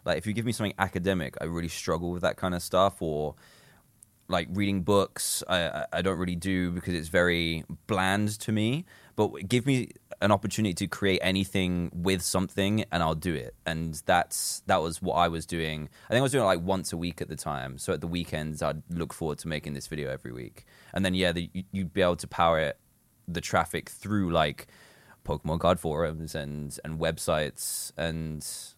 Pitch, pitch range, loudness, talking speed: 90 Hz, 80-100 Hz, -29 LUFS, 205 wpm